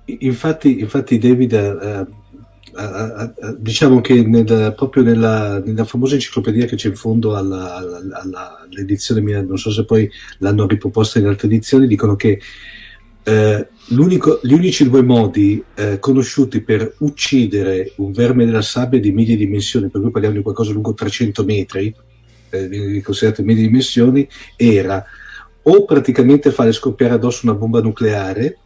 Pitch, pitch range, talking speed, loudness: 110 Hz, 105-125 Hz, 150 wpm, -15 LUFS